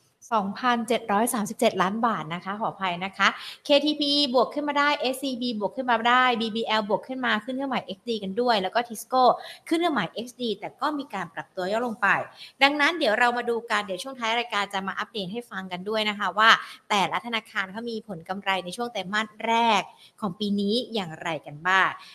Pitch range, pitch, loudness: 195-245 Hz, 225 Hz, -25 LUFS